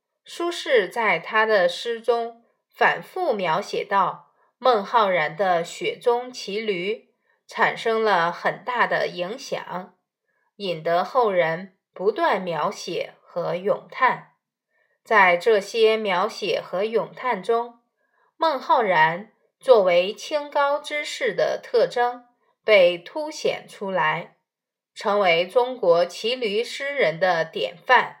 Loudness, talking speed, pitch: -22 LUFS, 160 characters per minute, 245 Hz